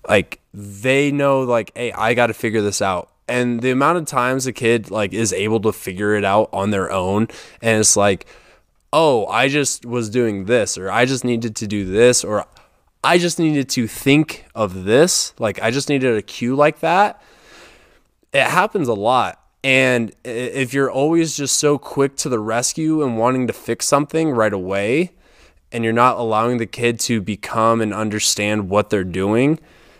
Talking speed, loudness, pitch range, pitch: 190 wpm, -18 LUFS, 110-135 Hz, 120 Hz